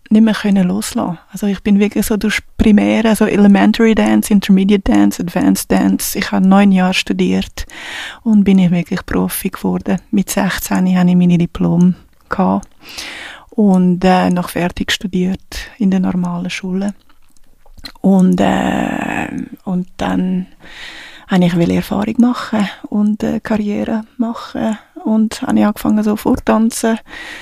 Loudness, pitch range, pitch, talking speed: -14 LUFS, 180-220 Hz, 200 Hz, 135 wpm